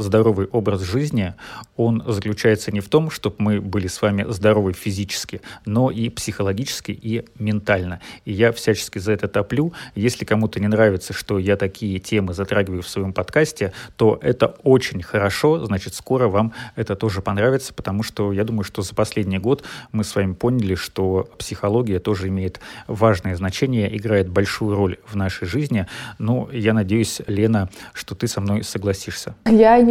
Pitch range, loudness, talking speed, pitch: 100-115 Hz, -21 LUFS, 165 wpm, 105 Hz